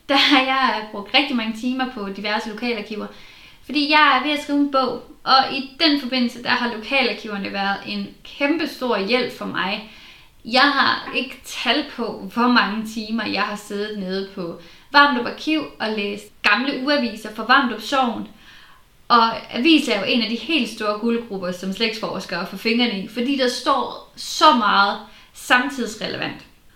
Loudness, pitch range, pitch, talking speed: -20 LUFS, 210-265 Hz, 240 Hz, 170 wpm